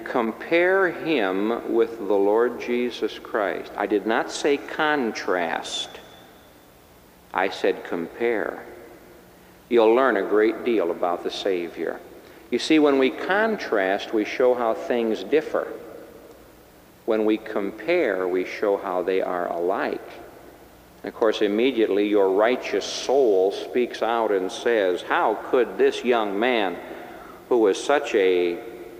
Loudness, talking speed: -23 LUFS, 130 wpm